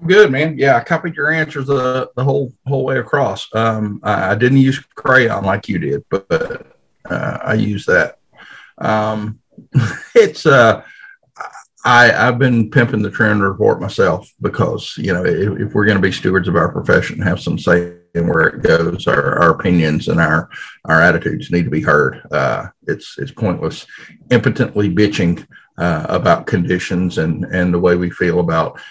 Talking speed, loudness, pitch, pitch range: 175 wpm, -15 LUFS, 110 Hz, 90-135 Hz